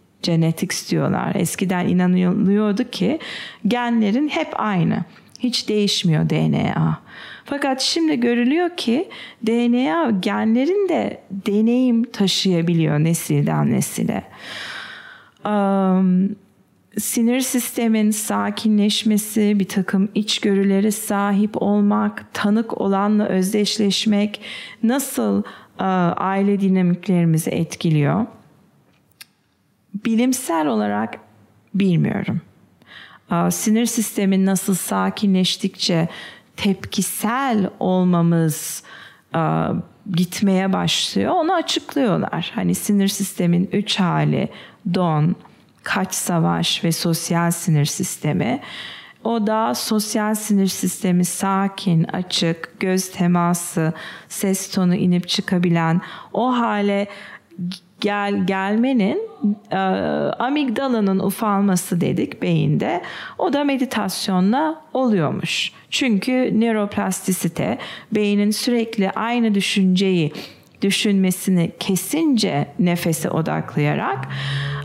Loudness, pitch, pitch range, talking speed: -20 LUFS, 200 Hz, 180-225 Hz, 80 wpm